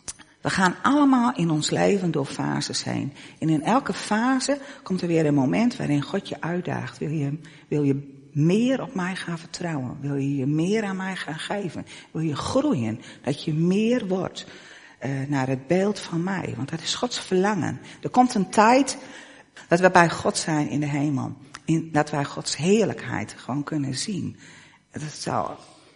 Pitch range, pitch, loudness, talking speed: 145-200 Hz, 165 Hz, -24 LUFS, 185 wpm